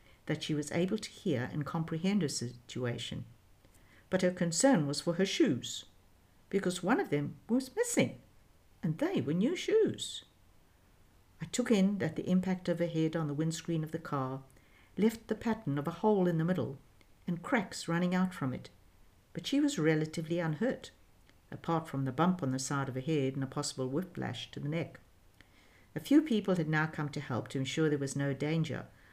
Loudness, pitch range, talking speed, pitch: -33 LUFS, 120-175 Hz, 195 wpm, 150 Hz